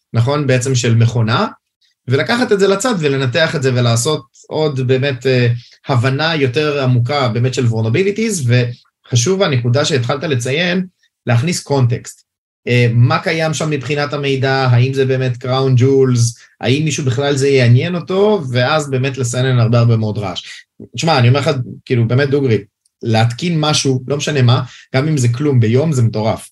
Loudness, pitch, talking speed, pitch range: -15 LUFS, 130 Hz, 160 wpm, 120-150 Hz